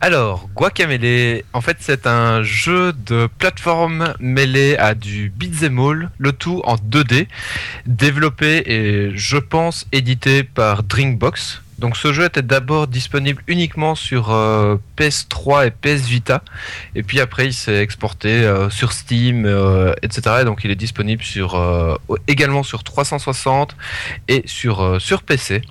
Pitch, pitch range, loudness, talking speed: 125 Hz, 110-145 Hz, -16 LUFS, 145 wpm